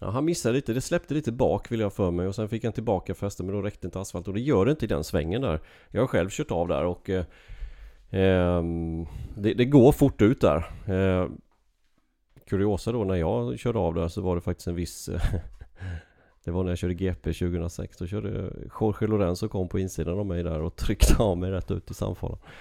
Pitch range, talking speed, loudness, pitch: 85-105 Hz, 235 wpm, -27 LUFS, 95 Hz